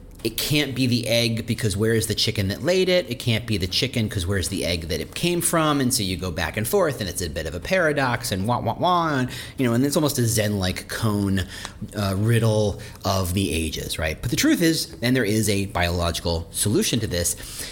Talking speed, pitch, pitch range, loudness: 240 wpm, 110 Hz, 95-125 Hz, -23 LUFS